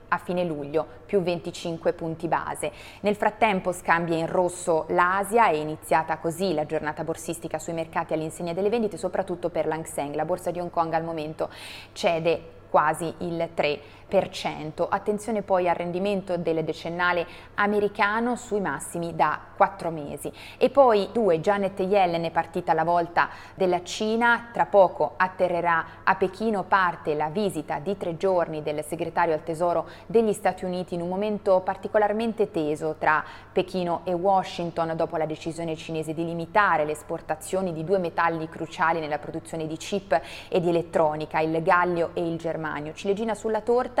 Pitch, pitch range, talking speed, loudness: 170 Hz, 160-195 Hz, 160 wpm, -26 LUFS